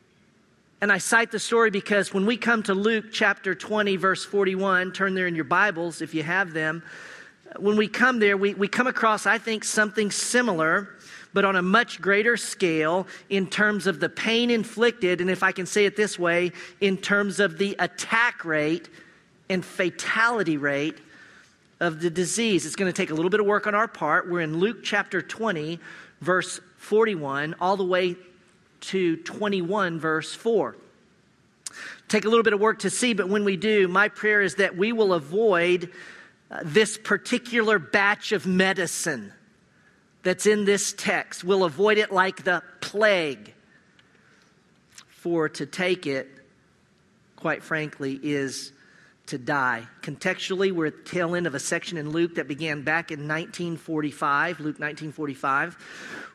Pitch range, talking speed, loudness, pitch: 170-210 Hz, 165 wpm, -24 LUFS, 190 Hz